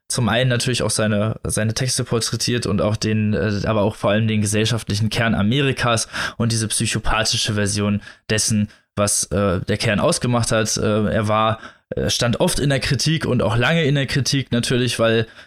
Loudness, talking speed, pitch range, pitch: -19 LUFS, 180 wpm, 105-120 Hz, 110 Hz